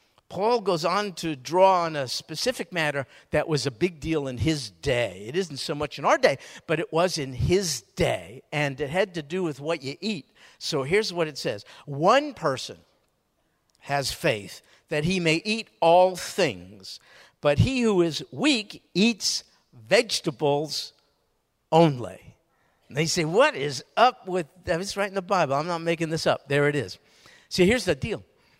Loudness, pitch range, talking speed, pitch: -25 LUFS, 145-185 Hz, 185 wpm, 165 Hz